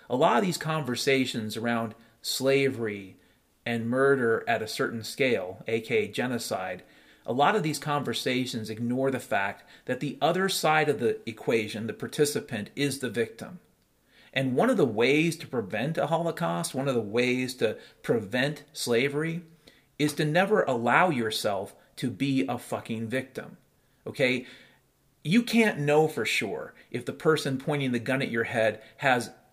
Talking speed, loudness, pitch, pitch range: 155 wpm, -27 LUFS, 135 Hz, 120-155 Hz